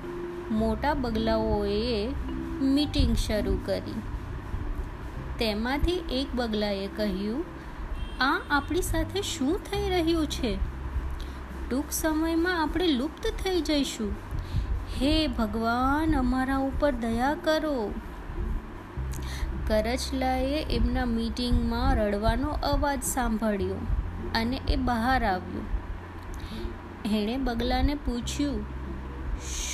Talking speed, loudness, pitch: 85 wpm, -29 LUFS, 230 Hz